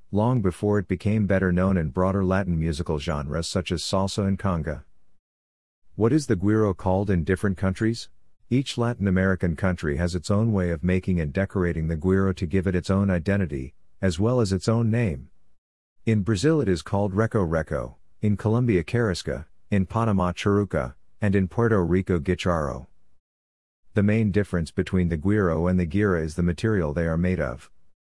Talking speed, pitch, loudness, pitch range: 180 wpm, 95 Hz, -24 LUFS, 85-105 Hz